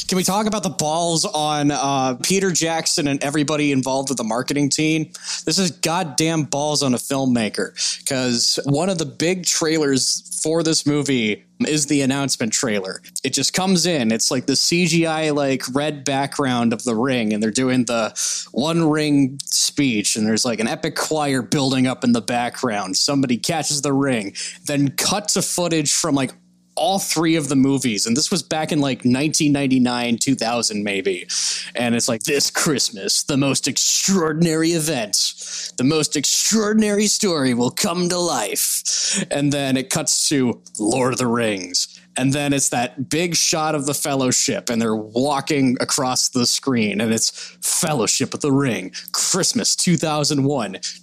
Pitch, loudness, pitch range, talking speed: 145 Hz, -19 LUFS, 130-160 Hz, 165 wpm